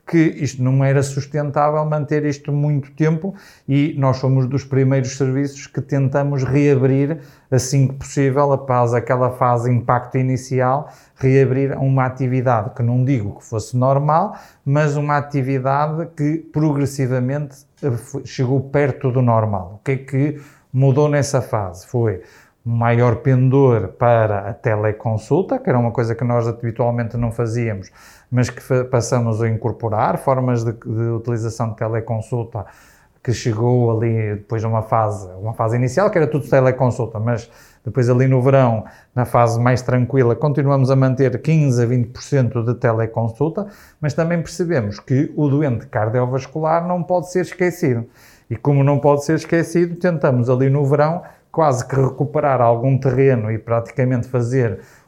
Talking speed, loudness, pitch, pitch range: 150 wpm, -18 LUFS, 130 Hz, 120-145 Hz